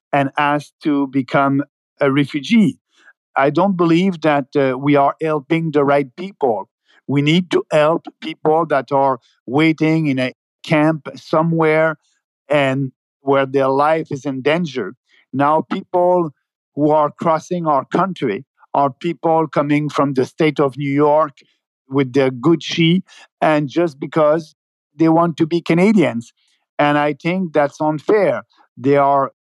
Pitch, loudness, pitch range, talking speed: 150 Hz, -17 LUFS, 140-165 Hz, 140 wpm